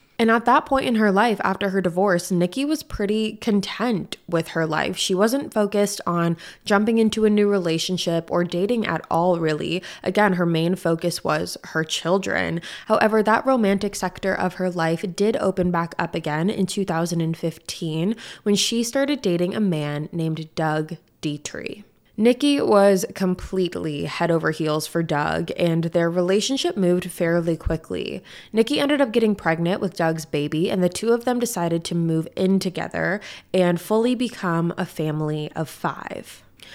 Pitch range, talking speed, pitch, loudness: 165-210 Hz, 165 wpm, 180 Hz, -22 LUFS